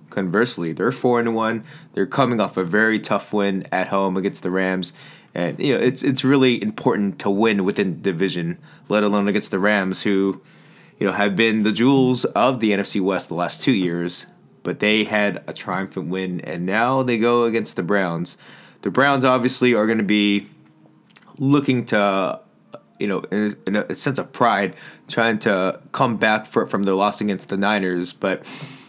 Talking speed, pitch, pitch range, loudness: 190 wpm, 105 Hz, 95-115 Hz, -20 LUFS